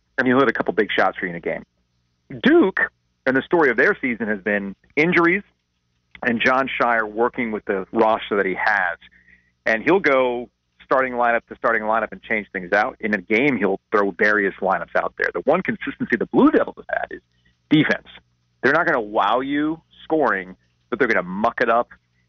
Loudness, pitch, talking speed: -20 LUFS, 105 Hz, 205 wpm